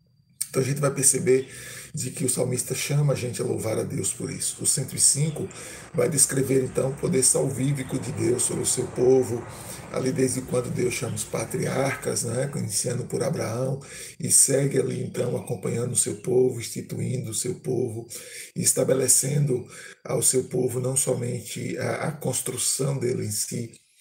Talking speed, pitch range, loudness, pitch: 165 wpm, 125-135 Hz, -24 LUFS, 130 Hz